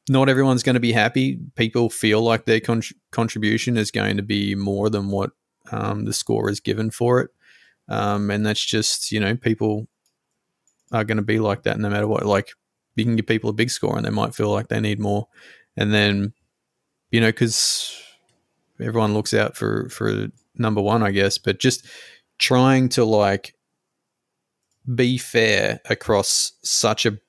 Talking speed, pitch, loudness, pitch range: 180 wpm, 110 Hz, -21 LUFS, 105-120 Hz